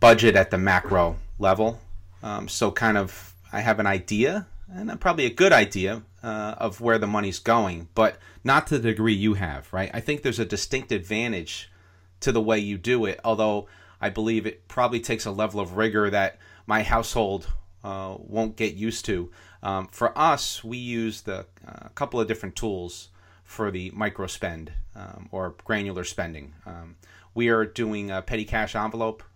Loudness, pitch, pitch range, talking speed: -25 LUFS, 105 Hz, 95-115 Hz, 180 wpm